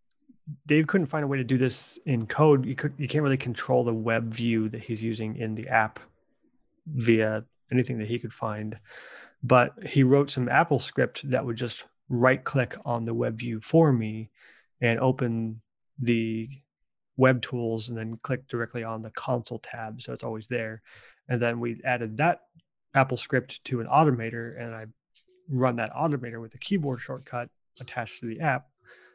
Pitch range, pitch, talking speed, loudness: 115-135 Hz, 120 Hz, 180 wpm, -27 LUFS